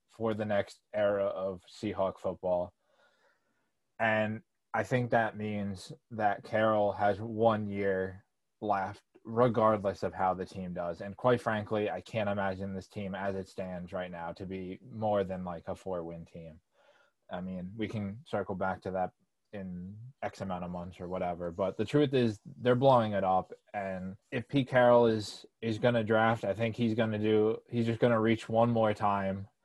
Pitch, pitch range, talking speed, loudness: 100 Hz, 95-115 Hz, 180 wpm, -32 LUFS